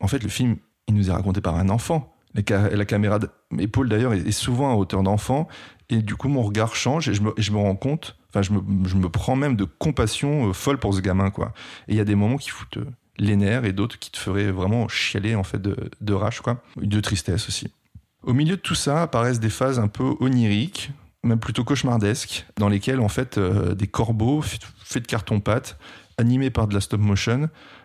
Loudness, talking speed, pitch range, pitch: -23 LUFS, 220 wpm, 100-125 Hz, 110 Hz